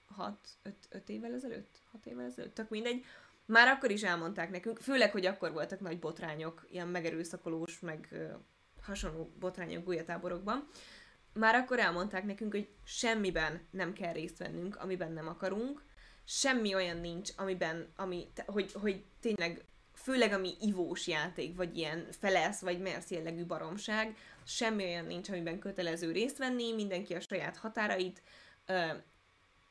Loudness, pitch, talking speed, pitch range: -36 LUFS, 185 Hz, 145 wpm, 170-215 Hz